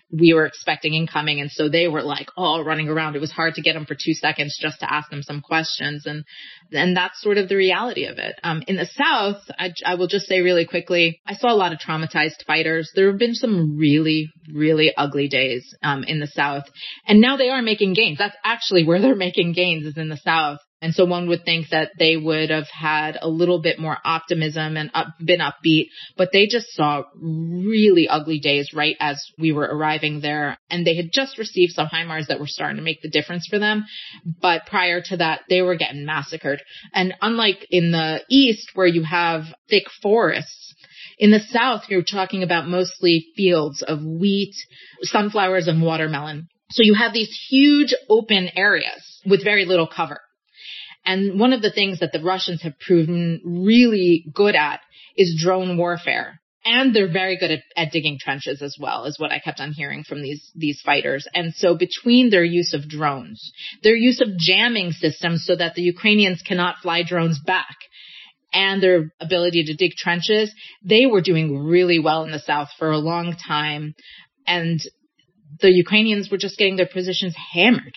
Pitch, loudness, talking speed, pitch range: 170 Hz, -19 LUFS, 195 wpm, 155-195 Hz